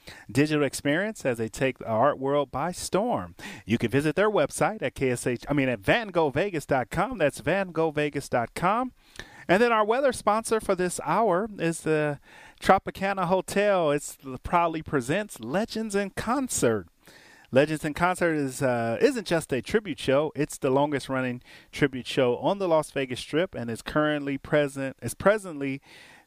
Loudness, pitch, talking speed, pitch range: -26 LUFS, 150 Hz, 160 wpm, 135-190 Hz